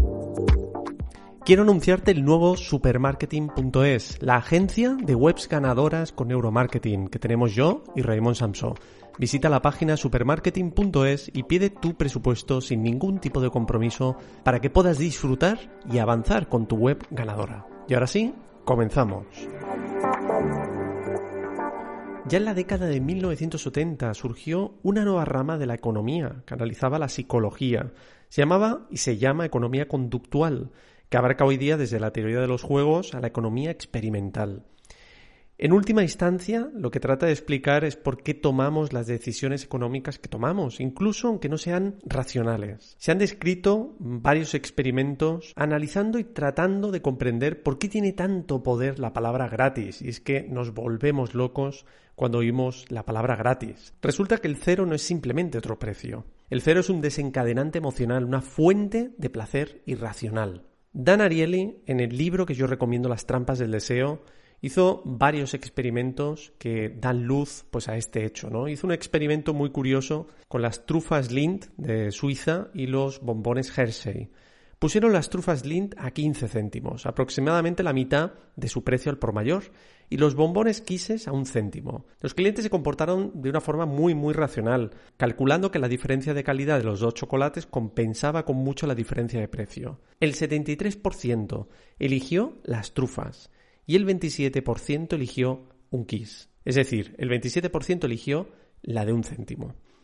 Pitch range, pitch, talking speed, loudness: 120-160 Hz, 135 Hz, 155 wpm, -25 LUFS